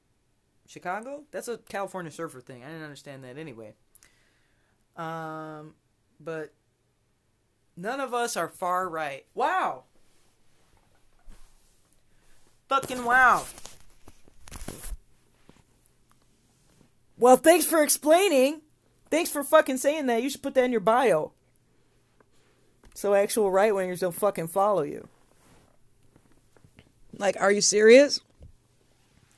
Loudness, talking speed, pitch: -24 LUFS, 100 wpm, 185 Hz